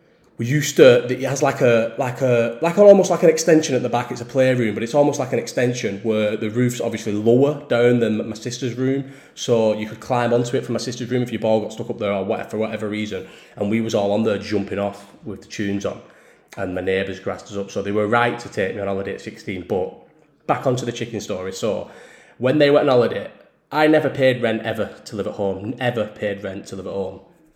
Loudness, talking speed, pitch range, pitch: -20 LUFS, 255 wpm, 105-130 Hz, 120 Hz